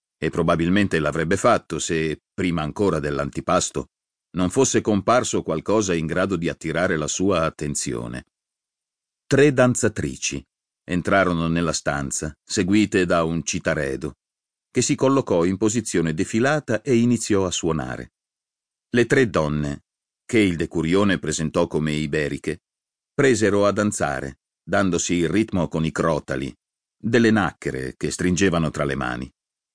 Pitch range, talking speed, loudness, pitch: 75-105 Hz, 125 wpm, -22 LUFS, 85 Hz